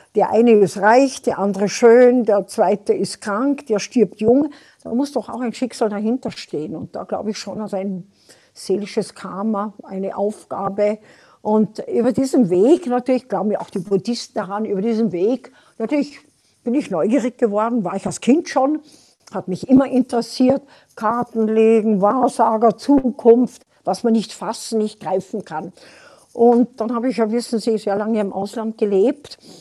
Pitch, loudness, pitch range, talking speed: 225 Hz, -19 LUFS, 200-245 Hz, 170 wpm